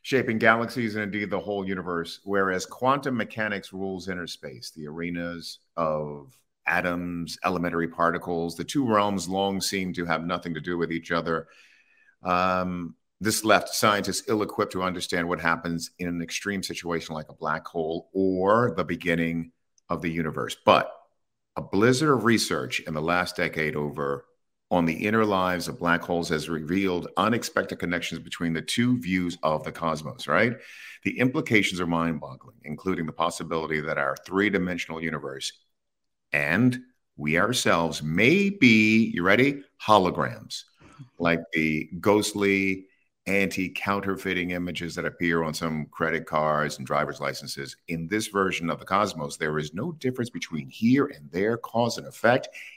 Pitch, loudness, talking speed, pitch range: 90 Hz, -26 LUFS, 155 wpm, 85-100 Hz